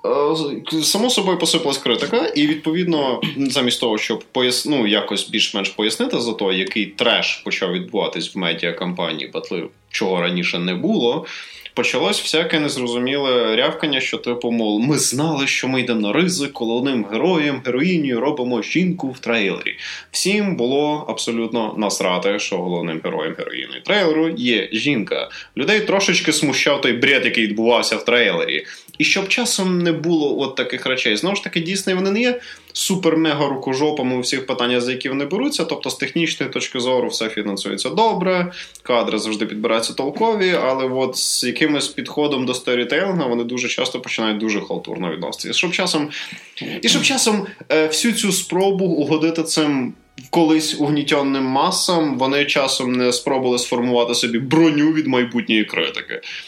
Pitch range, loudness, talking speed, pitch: 120-165 Hz, -19 LUFS, 150 wpm, 140 Hz